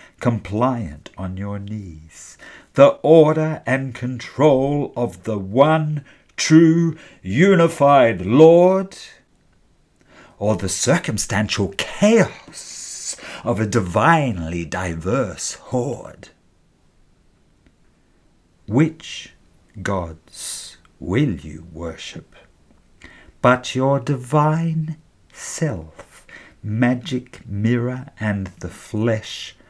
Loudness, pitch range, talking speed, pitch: -19 LUFS, 95-145 Hz, 75 wpm, 120 Hz